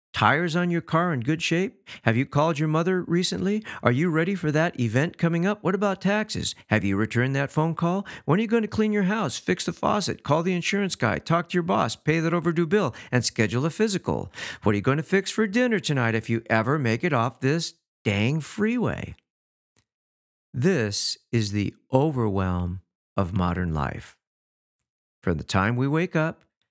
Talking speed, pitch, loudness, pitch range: 200 wpm, 150 Hz, -25 LUFS, 110-175 Hz